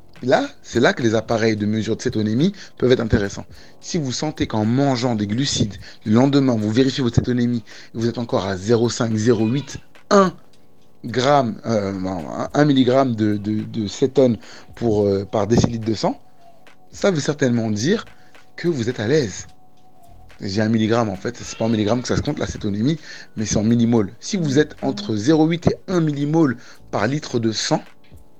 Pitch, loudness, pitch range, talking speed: 120 Hz, -20 LUFS, 110-135 Hz, 180 wpm